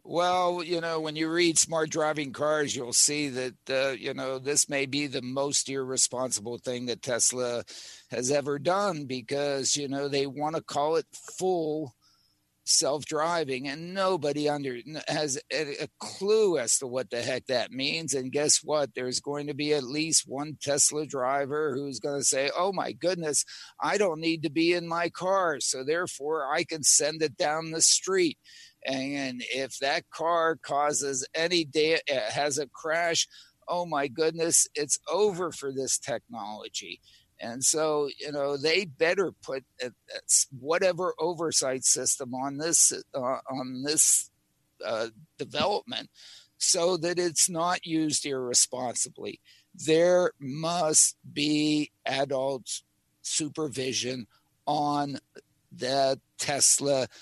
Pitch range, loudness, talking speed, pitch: 135-165 Hz, -27 LUFS, 140 wpm, 150 Hz